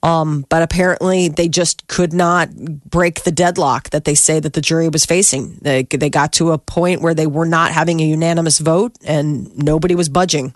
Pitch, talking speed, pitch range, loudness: 165 Hz, 205 wpm, 155-175 Hz, -15 LUFS